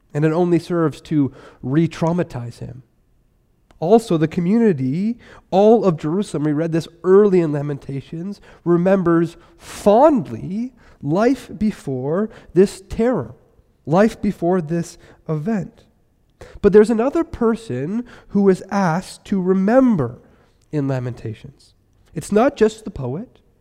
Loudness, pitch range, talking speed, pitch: -18 LUFS, 150-210 Hz, 115 wpm, 175 Hz